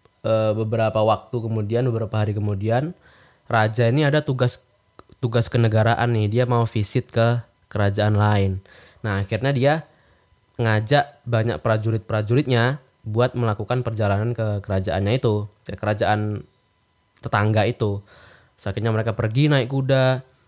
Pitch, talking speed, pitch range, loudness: 115 Hz, 120 wpm, 105-125 Hz, -22 LUFS